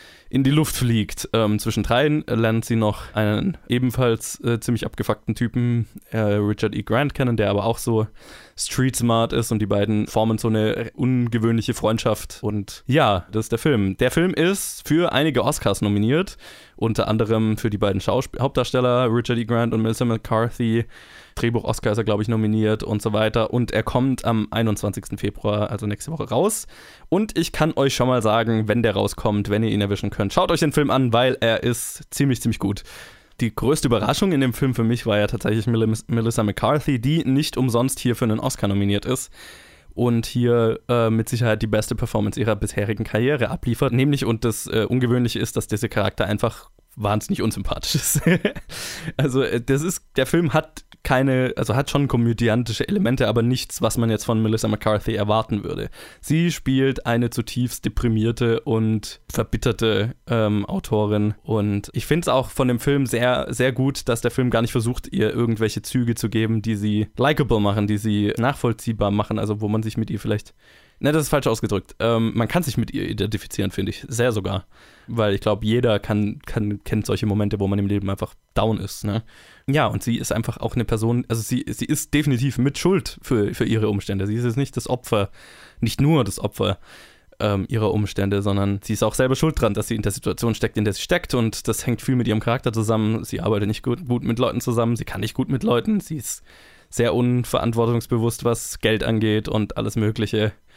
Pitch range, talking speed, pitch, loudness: 105-125 Hz, 200 wpm, 115 Hz, -22 LUFS